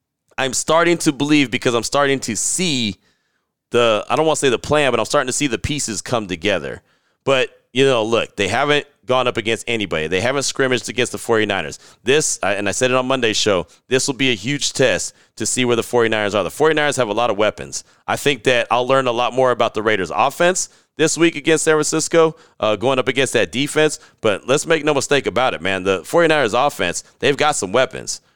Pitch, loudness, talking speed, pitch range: 130 Hz, -18 LUFS, 225 wpm, 115-145 Hz